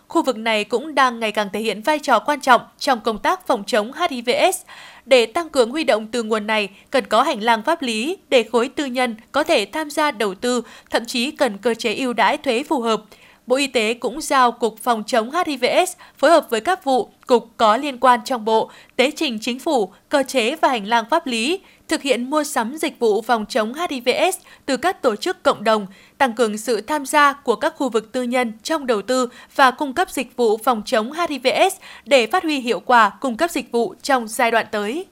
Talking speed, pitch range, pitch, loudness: 230 wpm, 230-305 Hz, 255 Hz, -19 LUFS